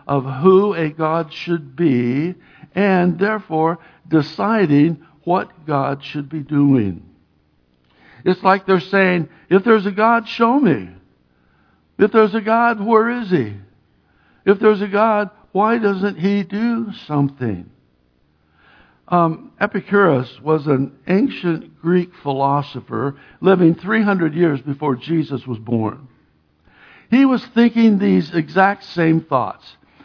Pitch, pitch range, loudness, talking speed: 165 Hz, 135-200 Hz, -17 LUFS, 120 wpm